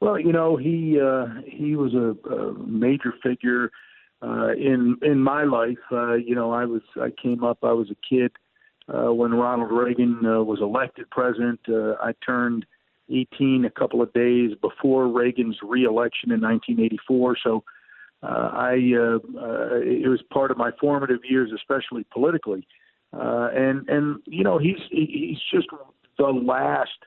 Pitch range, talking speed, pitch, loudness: 120-135 Hz, 160 wpm, 125 Hz, -23 LUFS